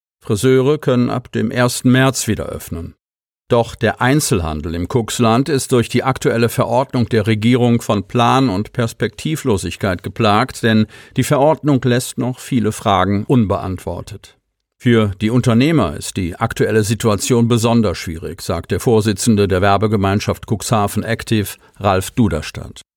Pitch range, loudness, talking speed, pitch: 100-125 Hz, -16 LUFS, 135 wpm, 115 Hz